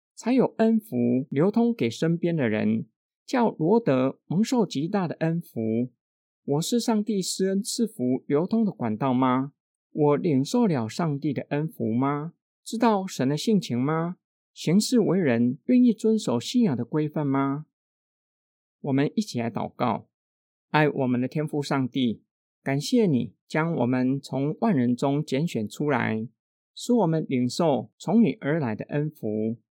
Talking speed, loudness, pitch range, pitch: 215 characters per minute, -25 LUFS, 125-200 Hz, 145 Hz